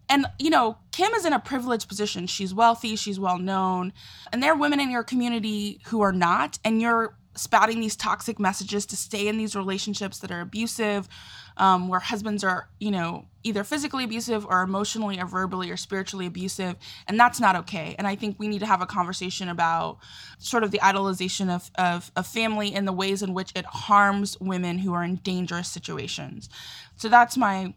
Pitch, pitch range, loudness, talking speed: 200 Hz, 185-225 Hz, -25 LUFS, 200 wpm